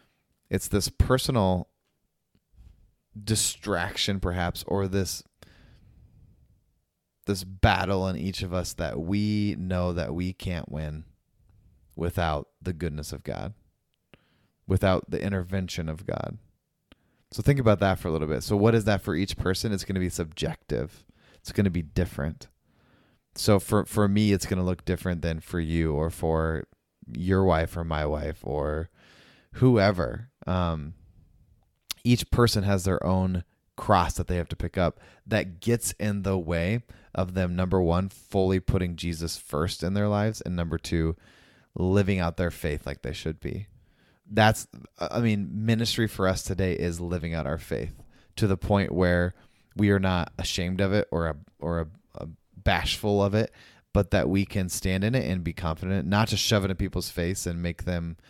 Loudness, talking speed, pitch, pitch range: -27 LUFS, 170 wpm, 95 Hz, 85-100 Hz